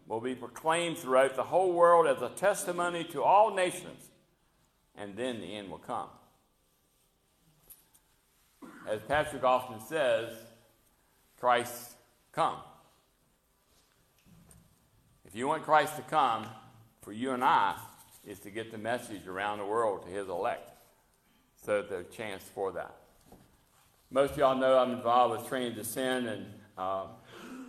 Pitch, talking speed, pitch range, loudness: 125 Hz, 140 wpm, 110-155 Hz, -30 LUFS